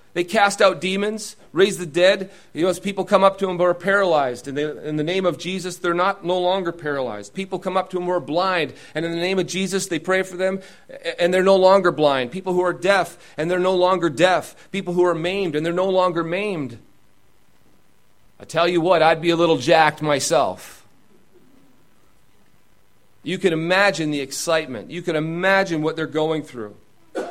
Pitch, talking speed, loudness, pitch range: 180 Hz, 205 wpm, -20 LUFS, 160-190 Hz